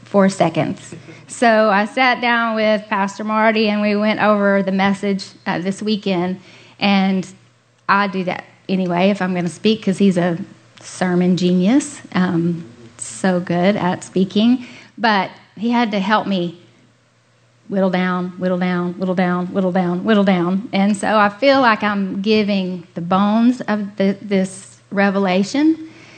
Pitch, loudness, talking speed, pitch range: 195 Hz, -17 LUFS, 155 wpm, 180-215 Hz